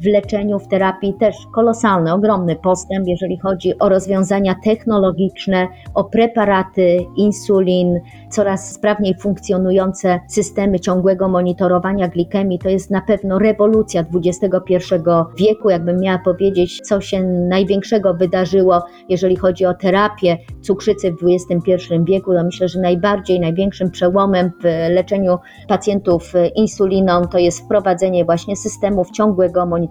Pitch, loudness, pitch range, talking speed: 190 Hz, -16 LUFS, 180-200 Hz, 125 wpm